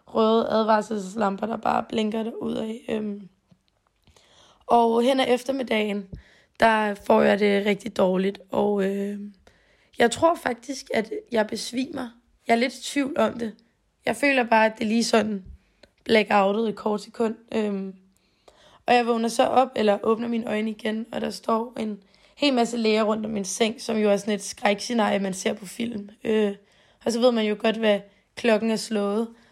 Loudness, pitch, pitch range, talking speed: -24 LUFS, 220 Hz, 205-235 Hz, 175 wpm